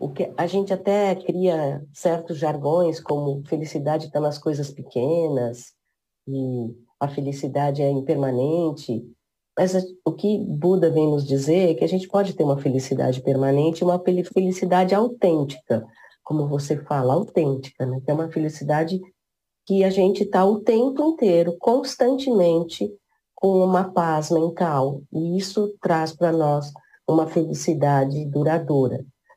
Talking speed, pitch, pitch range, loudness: 140 wpm, 160 Hz, 140-185 Hz, -22 LUFS